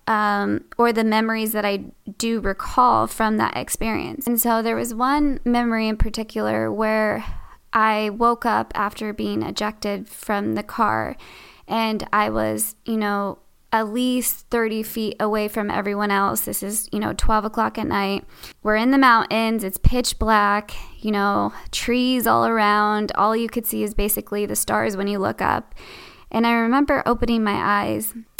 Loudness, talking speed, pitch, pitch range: -21 LUFS, 170 wpm, 220 Hz, 205-230 Hz